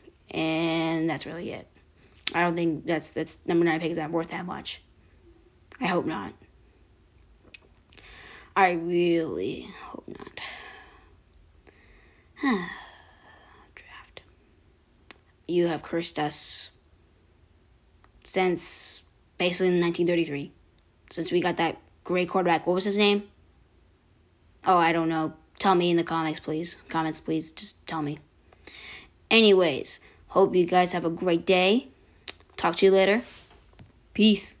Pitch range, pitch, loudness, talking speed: 145-180 Hz, 165 Hz, -25 LUFS, 125 wpm